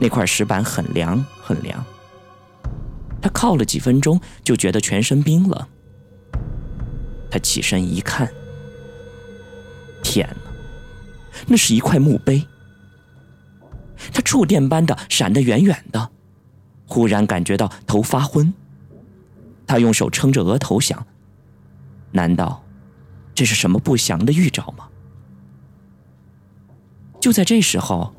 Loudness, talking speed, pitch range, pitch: -18 LUFS, 165 characters per minute, 100-145 Hz, 115 Hz